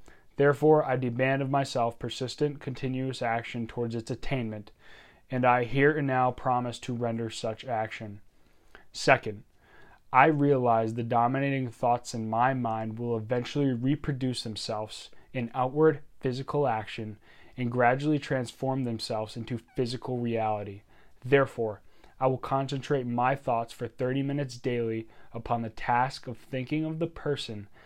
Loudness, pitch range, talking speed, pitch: -29 LUFS, 115-135 Hz, 135 wpm, 125 Hz